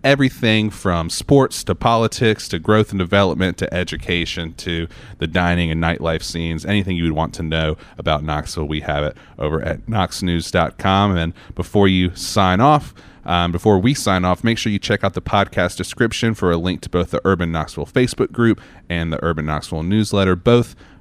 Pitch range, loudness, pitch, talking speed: 85-105 Hz, -18 LUFS, 90 Hz, 185 wpm